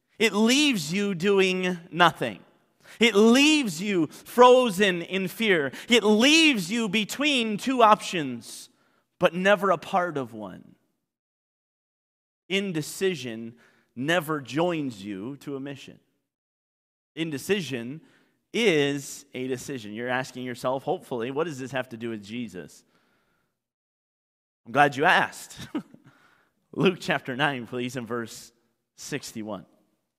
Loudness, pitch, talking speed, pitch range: -24 LUFS, 155 Hz, 115 wpm, 125-200 Hz